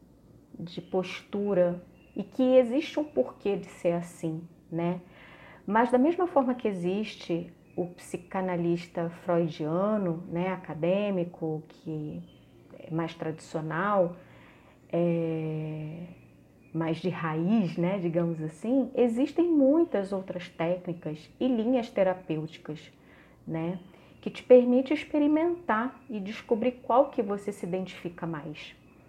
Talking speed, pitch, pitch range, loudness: 110 wpm, 180 Hz, 165-225 Hz, -29 LUFS